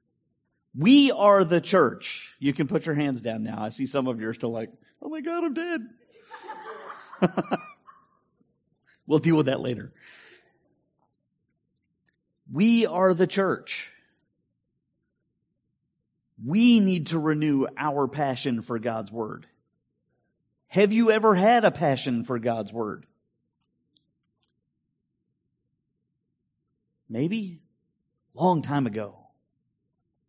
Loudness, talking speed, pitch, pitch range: -24 LUFS, 105 wpm, 155 Hz, 125-205 Hz